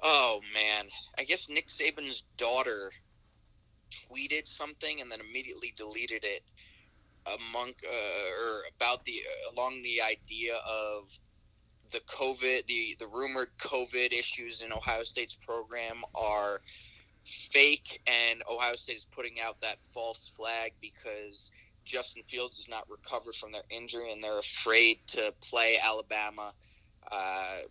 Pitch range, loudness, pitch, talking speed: 105-125 Hz, -31 LUFS, 115 Hz, 130 wpm